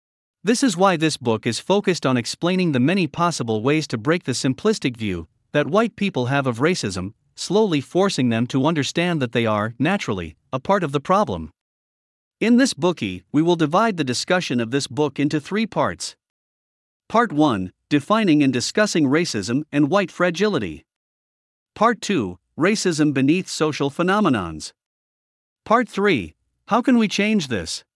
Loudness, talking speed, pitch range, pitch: -20 LUFS, 160 wpm, 120-190 Hz, 150 Hz